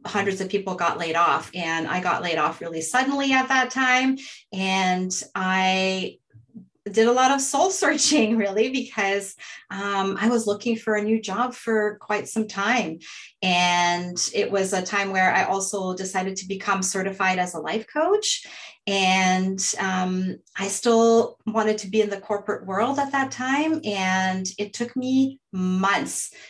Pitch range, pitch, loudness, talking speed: 185-235 Hz, 200 Hz, -23 LUFS, 165 wpm